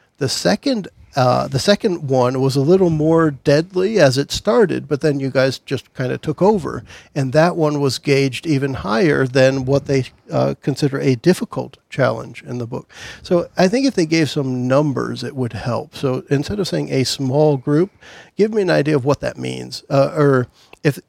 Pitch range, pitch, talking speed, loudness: 130-165 Hz, 140 Hz, 200 wpm, -18 LUFS